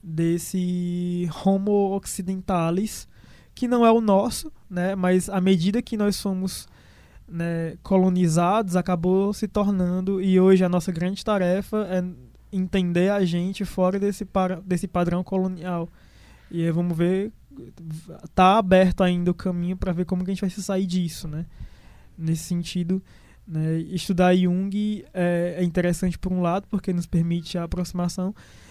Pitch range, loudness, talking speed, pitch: 175-195 Hz, -23 LUFS, 150 wpm, 185 Hz